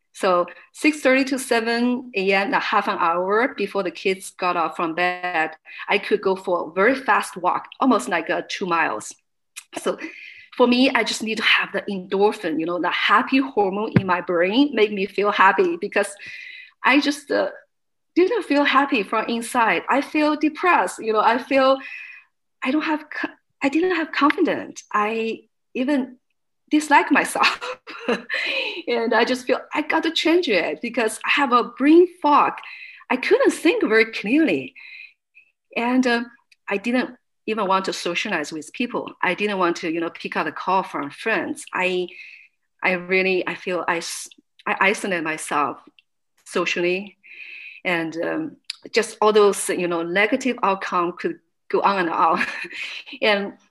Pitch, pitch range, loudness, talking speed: 225 Hz, 190-285 Hz, -21 LUFS, 160 wpm